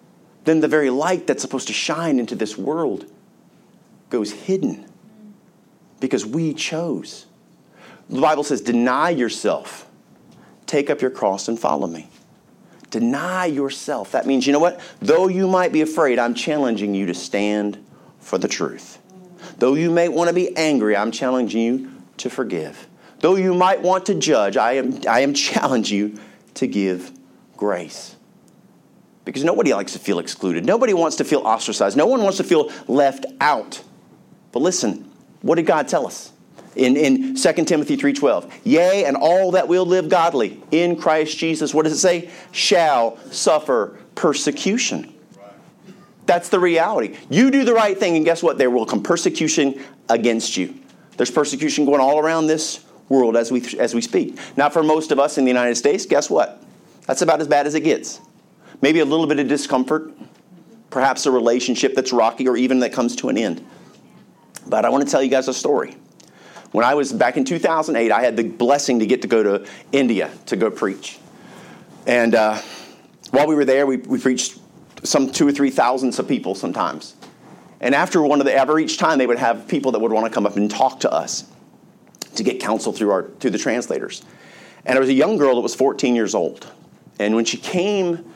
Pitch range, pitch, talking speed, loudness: 125-175 Hz, 145 Hz, 190 wpm, -19 LUFS